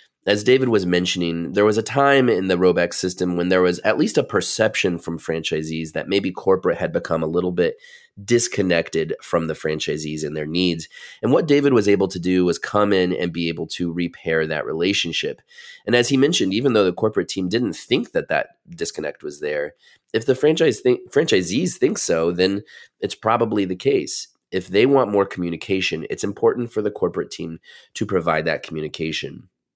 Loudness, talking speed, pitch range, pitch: -20 LUFS, 195 wpm, 85-130 Hz, 95 Hz